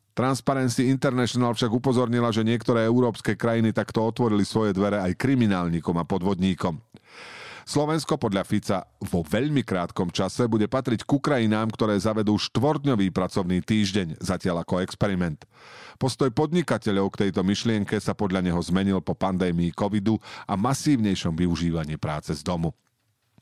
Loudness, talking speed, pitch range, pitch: -25 LUFS, 135 wpm, 95-120 Hz, 110 Hz